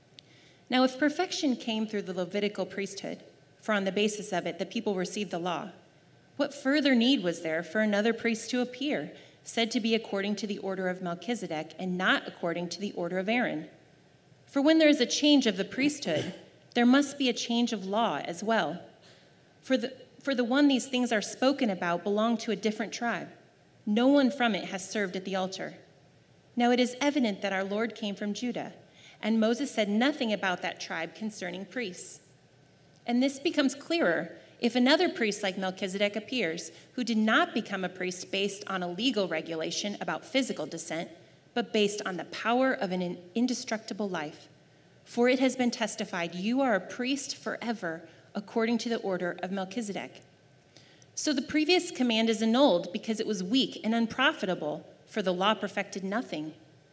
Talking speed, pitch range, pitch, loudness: 180 wpm, 185-250 Hz, 215 Hz, -29 LUFS